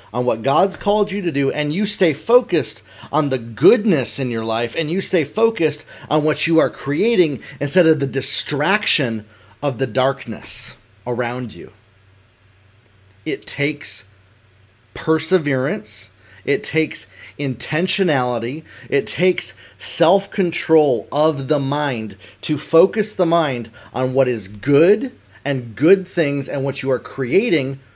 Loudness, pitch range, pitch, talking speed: -19 LUFS, 115-160 Hz, 135 Hz, 135 wpm